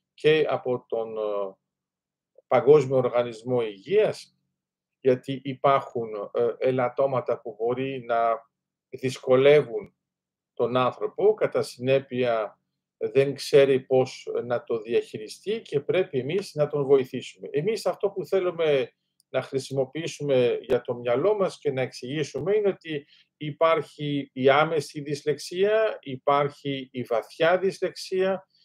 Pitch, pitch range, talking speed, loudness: 145 Hz, 130-190 Hz, 110 wpm, -25 LUFS